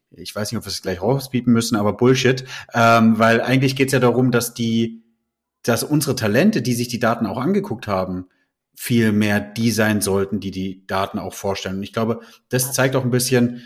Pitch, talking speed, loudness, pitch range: 115 Hz, 210 wpm, -19 LUFS, 105-125 Hz